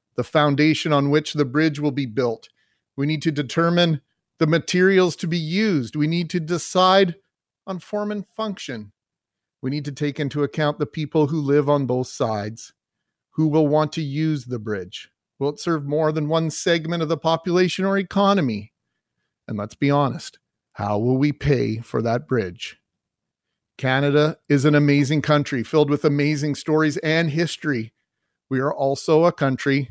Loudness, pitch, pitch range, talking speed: -21 LUFS, 150 Hz, 140-165 Hz, 170 wpm